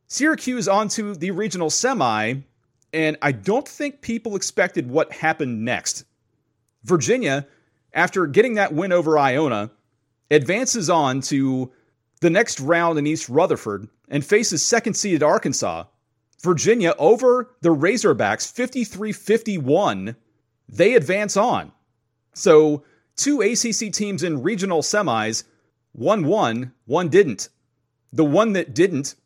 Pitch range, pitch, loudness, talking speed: 125-205 Hz, 155 Hz, -20 LUFS, 120 wpm